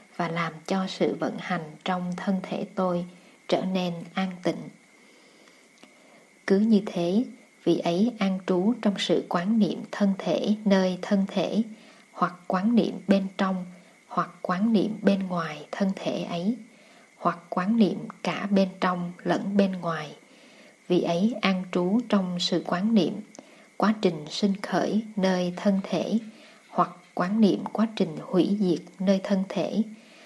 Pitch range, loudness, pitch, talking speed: 180-215 Hz, -26 LUFS, 195 Hz, 155 wpm